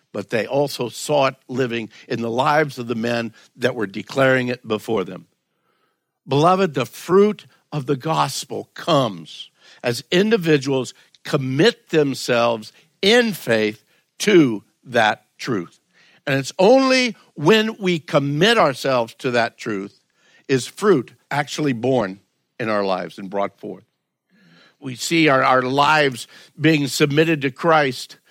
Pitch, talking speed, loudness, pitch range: 140 Hz, 130 wpm, -19 LUFS, 125-160 Hz